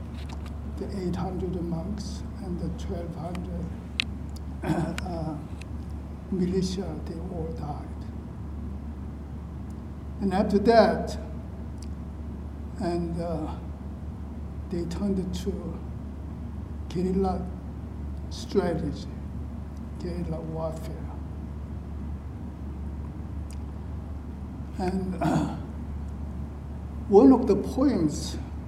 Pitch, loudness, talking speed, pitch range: 80 Hz, -30 LUFS, 60 wpm, 75-85 Hz